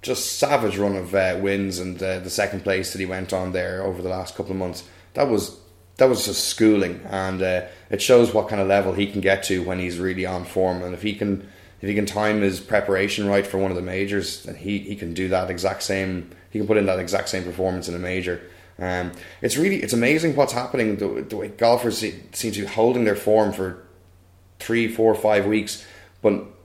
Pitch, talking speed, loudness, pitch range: 95 Hz, 235 wpm, -22 LUFS, 90-105 Hz